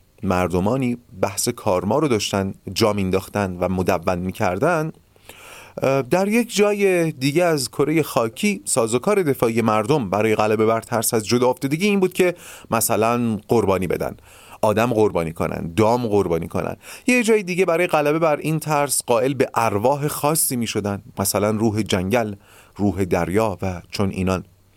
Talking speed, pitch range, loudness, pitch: 145 wpm, 100-150 Hz, -20 LUFS, 115 Hz